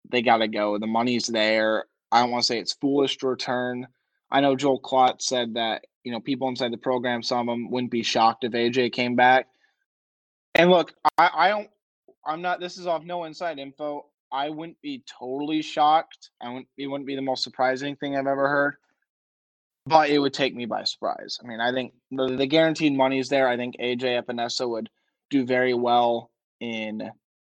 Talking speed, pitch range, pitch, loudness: 200 wpm, 120-145 Hz, 130 Hz, -24 LUFS